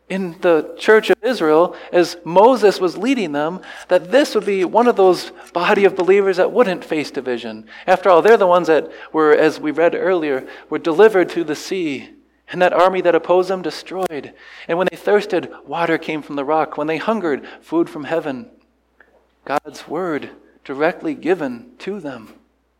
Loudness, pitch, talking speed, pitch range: -17 LUFS, 185 Hz, 180 wpm, 165-230 Hz